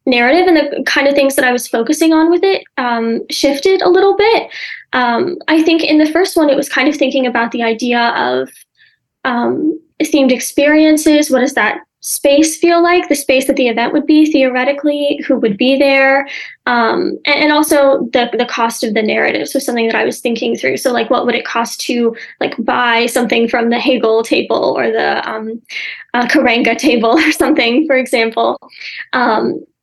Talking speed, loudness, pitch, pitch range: 195 wpm, -12 LUFS, 275 Hz, 240-305 Hz